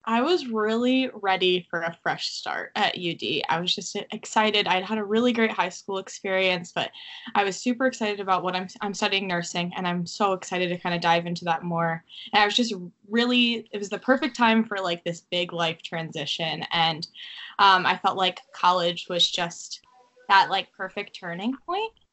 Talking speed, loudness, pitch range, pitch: 200 wpm, -25 LUFS, 175-220 Hz, 190 Hz